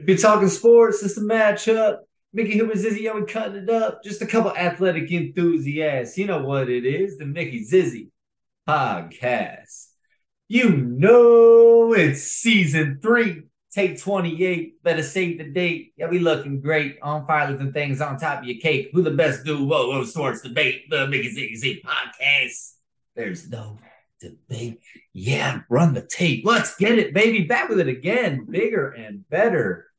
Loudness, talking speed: -20 LUFS, 165 wpm